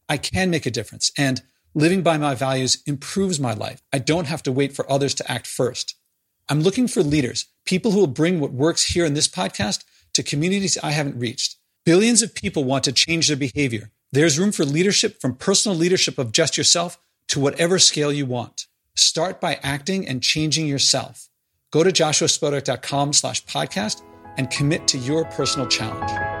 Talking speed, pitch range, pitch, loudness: 185 wpm, 135-170 Hz, 150 Hz, -20 LUFS